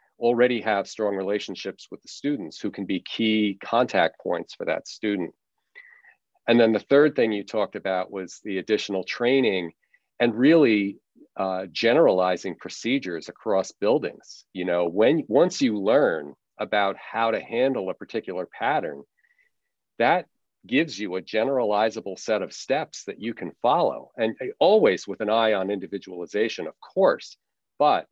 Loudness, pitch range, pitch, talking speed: -24 LUFS, 95-120 Hz, 105 Hz, 150 wpm